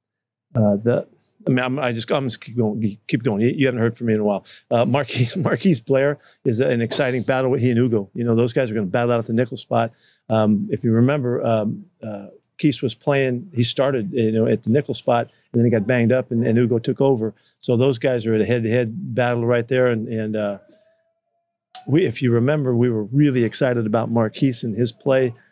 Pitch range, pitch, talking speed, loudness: 115-135 Hz, 120 Hz, 235 wpm, -20 LUFS